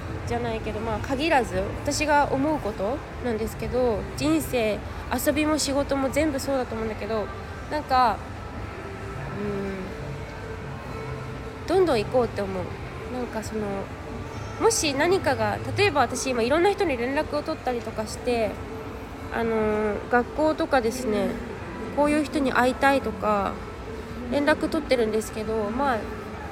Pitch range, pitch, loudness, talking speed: 215-300 Hz, 255 Hz, -26 LUFS, 290 characters per minute